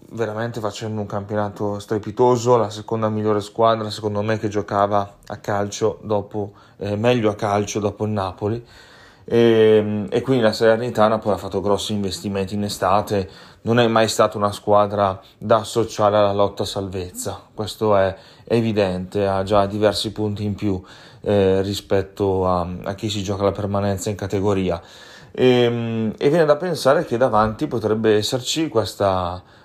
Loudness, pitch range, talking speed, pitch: -20 LUFS, 100-110 Hz, 155 wpm, 105 Hz